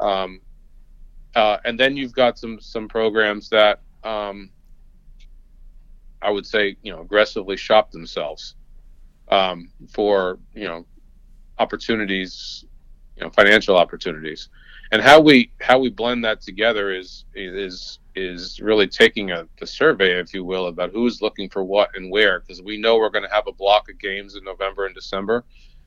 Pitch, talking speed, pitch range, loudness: 100 Hz, 160 wpm, 90-110 Hz, -19 LUFS